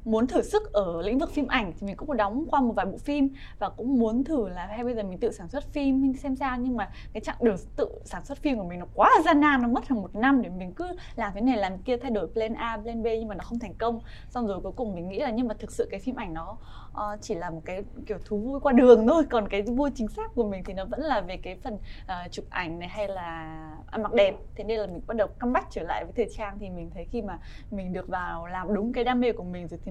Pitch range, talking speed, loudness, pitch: 195-255 Hz, 305 wpm, -27 LUFS, 225 Hz